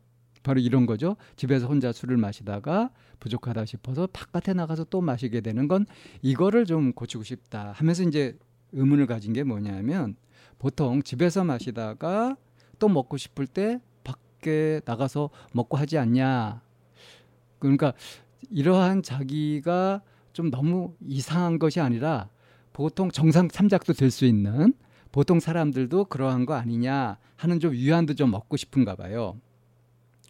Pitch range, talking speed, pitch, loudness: 120-165 Hz, 285 characters per minute, 135 Hz, -26 LUFS